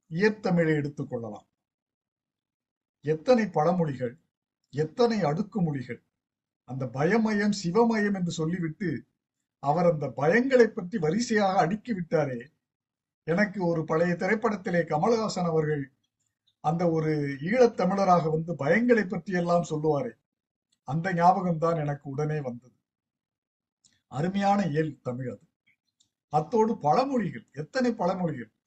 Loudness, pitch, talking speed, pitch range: -27 LUFS, 165 Hz, 95 wpm, 145-200 Hz